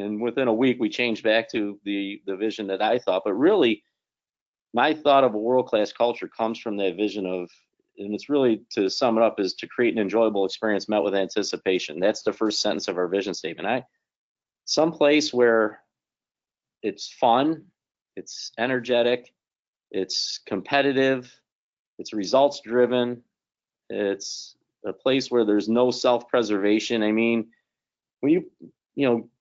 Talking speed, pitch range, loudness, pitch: 160 wpm, 105-125 Hz, -24 LUFS, 115 Hz